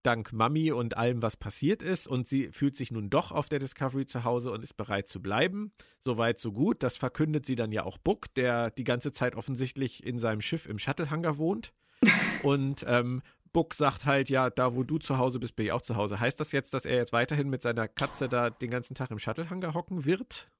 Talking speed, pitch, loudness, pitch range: 230 wpm, 130 Hz, -30 LUFS, 120-150 Hz